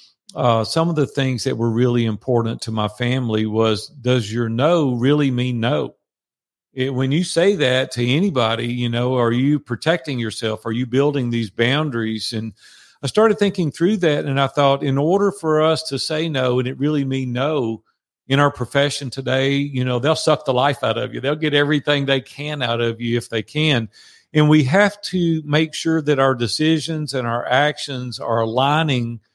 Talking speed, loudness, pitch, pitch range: 195 wpm, -19 LUFS, 135 Hz, 120-150 Hz